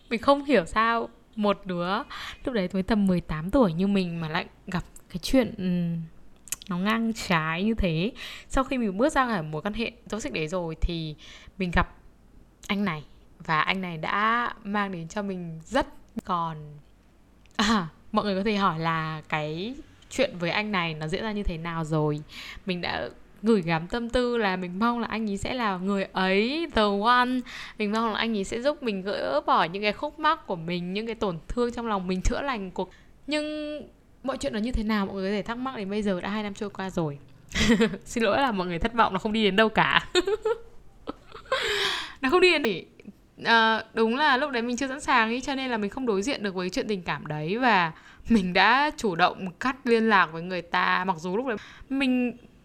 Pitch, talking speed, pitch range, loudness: 210 Hz, 220 wpm, 180-235 Hz, -26 LUFS